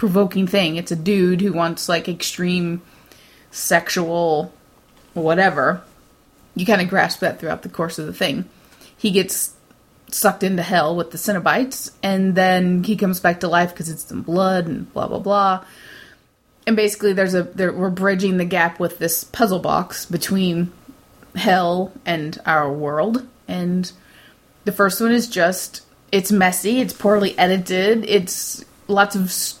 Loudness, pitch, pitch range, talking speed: -19 LUFS, 185 Hz, 175-200 Hz, 155 wpm